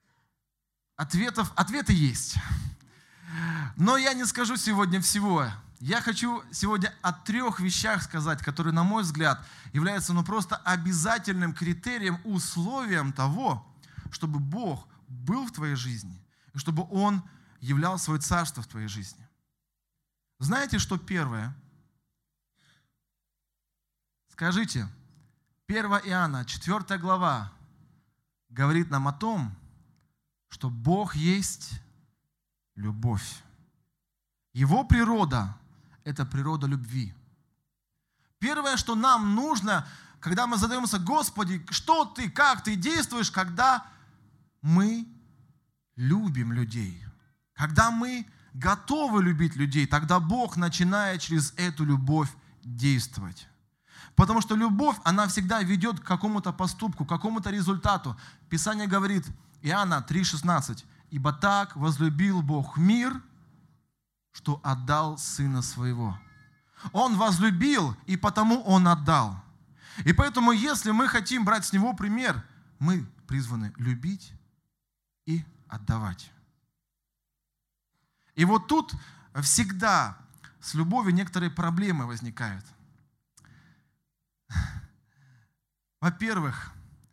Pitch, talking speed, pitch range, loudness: 160 Hz, 100 wpm, 140-195 Hz, -27 LUFS